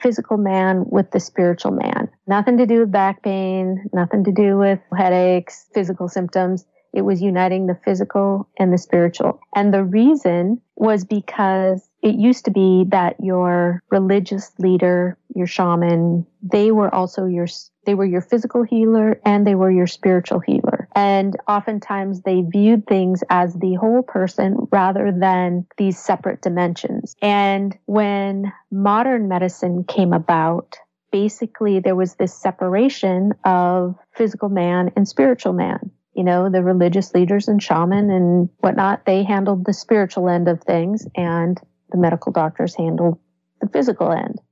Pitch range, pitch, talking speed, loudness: 180-205 Hz, 190 Hz, 150 wpm, -18 LUFS